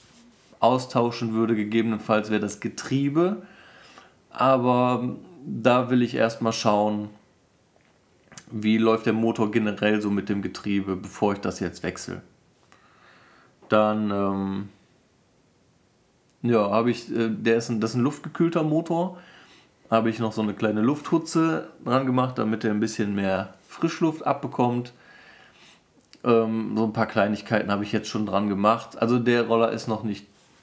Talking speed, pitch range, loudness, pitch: 145 wpm, 105-125 Hz, -24 LUFS, 115 Hz